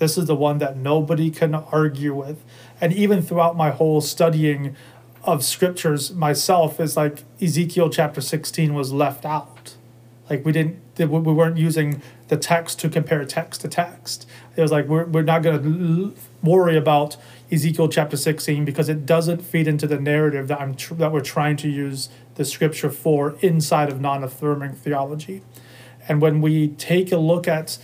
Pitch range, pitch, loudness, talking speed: 145-165 Hz, 155 Hz, -20 LUFS, 175 wpm